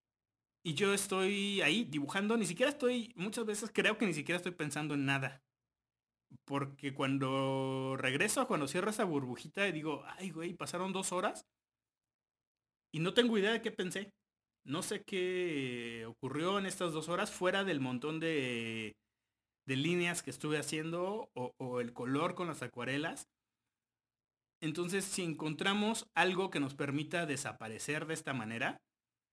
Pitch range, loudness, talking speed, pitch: 135-190 Hz, -36 LUFS, 150 wpm, 155 Hz